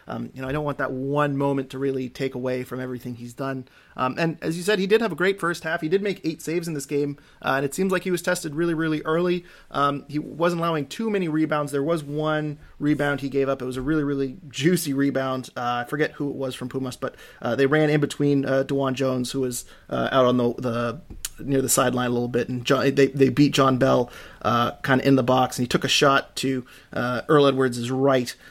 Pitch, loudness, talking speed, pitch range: 140 Hz, -23 LUFS, 255 wpm, 130-155 Hz